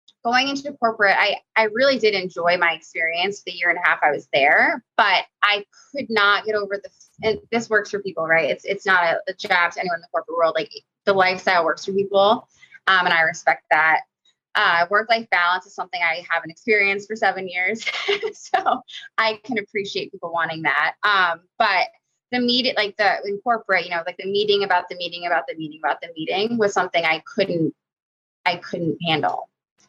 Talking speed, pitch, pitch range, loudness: 205 wpm, 200 Hz, 175-225 Hz, -20 LUFS